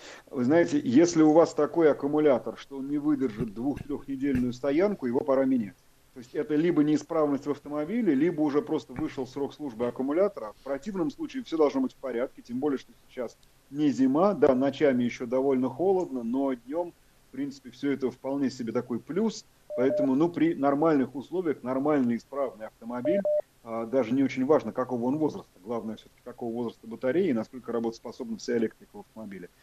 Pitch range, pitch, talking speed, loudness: 125-195 Hz, 145 Hz, 175 wpm, -28 LUFS